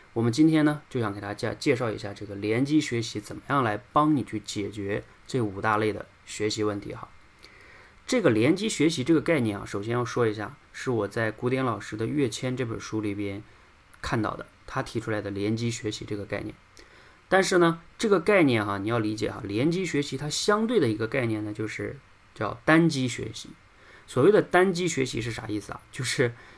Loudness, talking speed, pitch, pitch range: -26 LUFS, 305 characters per minute, 115 Hz, 105-140 Hz